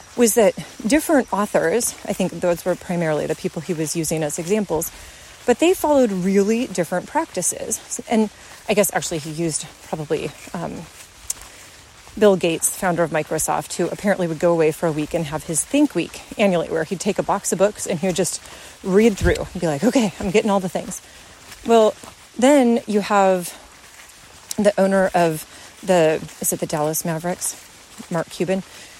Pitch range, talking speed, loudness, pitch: 170-215 Hz, 175 wpm, -20 LUFS, 190 Hz